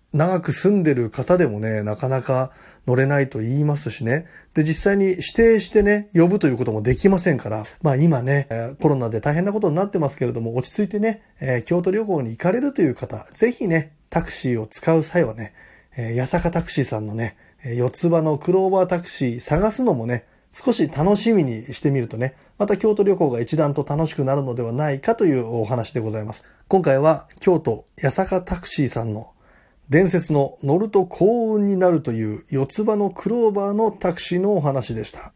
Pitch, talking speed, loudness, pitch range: 155 Hz, 380 characters per minute, -21 LUFS, 125-190 Hz